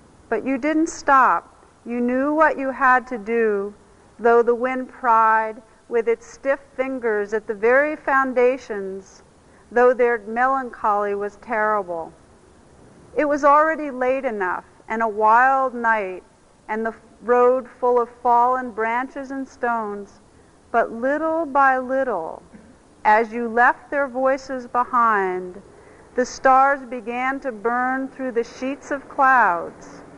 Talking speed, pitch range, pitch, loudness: 130 wpm, 225-270 Hz, 250 Hz, -20 LUFS